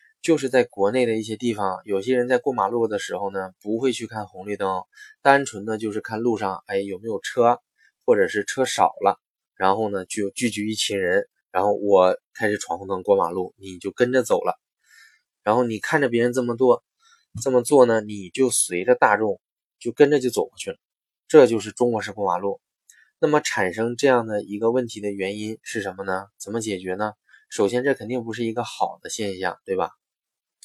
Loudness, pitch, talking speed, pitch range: -22 LUFS, 115 Hz, 290 characters per minute, 100-125 Hz